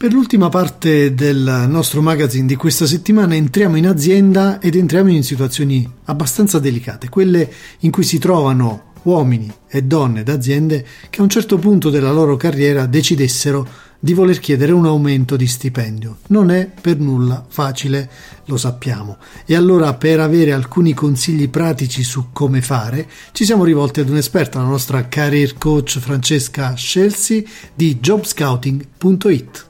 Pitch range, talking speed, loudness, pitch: 135-175 Hz, 150 wpm, -14 LUFS, 150 Hz